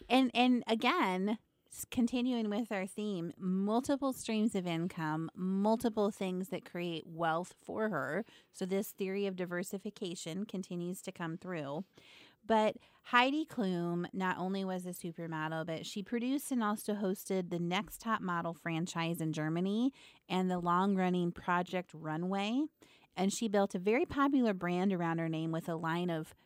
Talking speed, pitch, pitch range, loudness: 155 wpm, 190 Hz, 170-215 Hz, -35 LUFS